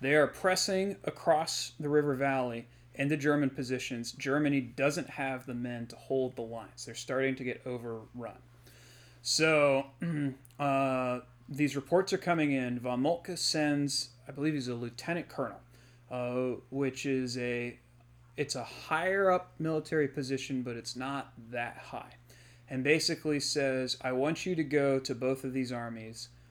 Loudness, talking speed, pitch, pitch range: -32 LUFS, 155 wpm, 130 Hz, 120-145 Hz